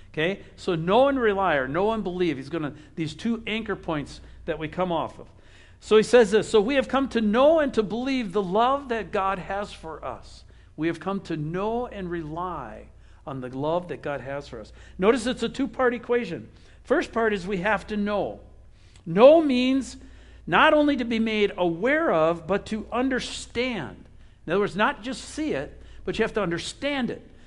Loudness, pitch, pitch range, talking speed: -24 LUFS, 205 Hz, 165-240 Hz, 200 wpm